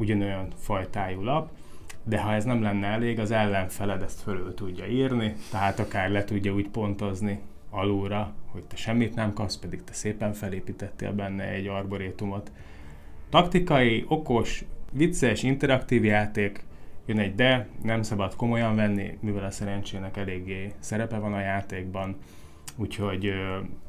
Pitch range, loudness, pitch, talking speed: 95-110 Hz, -28 LUFS, 100 Hz, 140 wpm